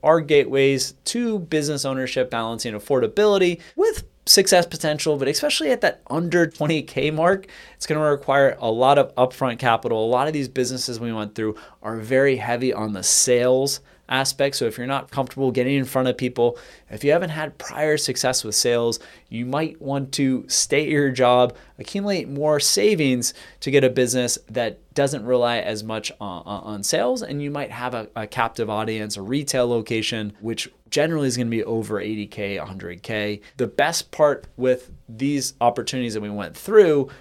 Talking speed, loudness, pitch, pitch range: 180 wpm, -21 LUFS, 130 Hz, 115-145 Hz